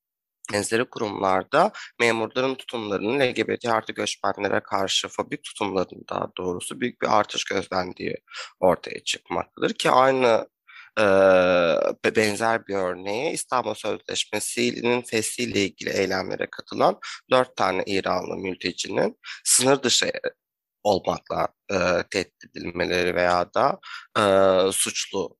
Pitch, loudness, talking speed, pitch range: 110 Hz, -23 LUFS, 100 wpm, 95-120 Hz